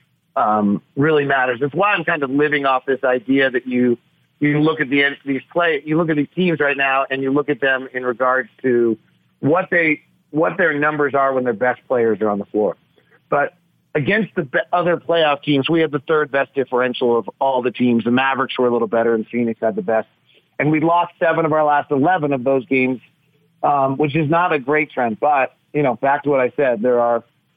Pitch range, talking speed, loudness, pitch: 125-150 Hz, 225 wpm, -18 LUFS, 135 Hz